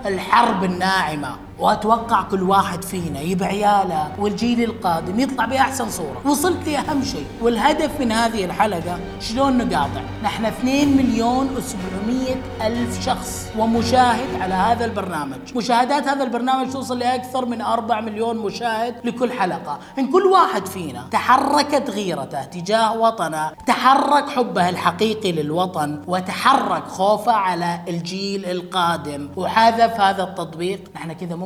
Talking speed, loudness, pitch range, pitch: 125 wpm, -20 LUFS, 185-245 Hz, 220 Hz